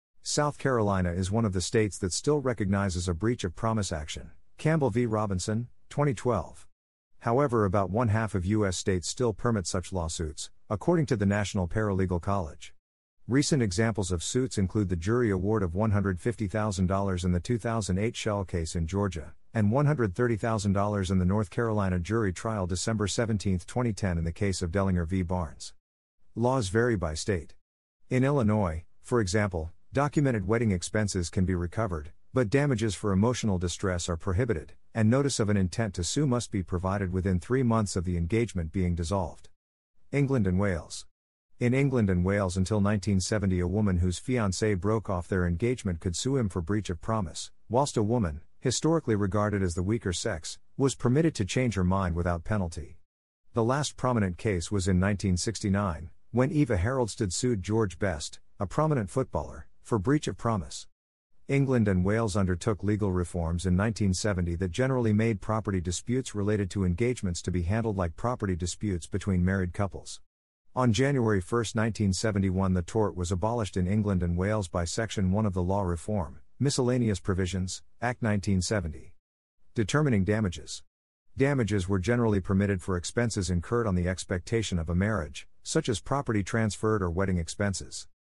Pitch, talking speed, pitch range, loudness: 100 Hz, 165 wpm, 90-115 Hz, -28 LUFS